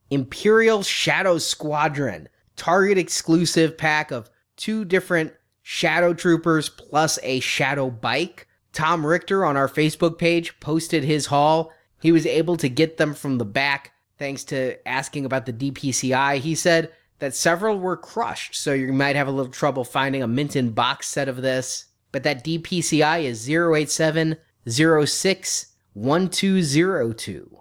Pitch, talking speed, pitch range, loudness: 155 Hz, 140 wpm, 135-170 Hz, -21 LUFS